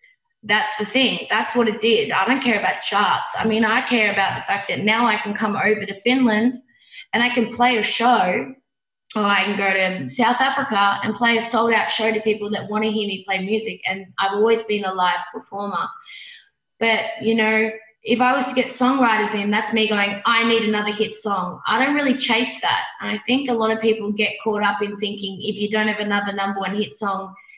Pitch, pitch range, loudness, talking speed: 220 Hz, 205-235 Hz, -20 LUFS, 230 wpm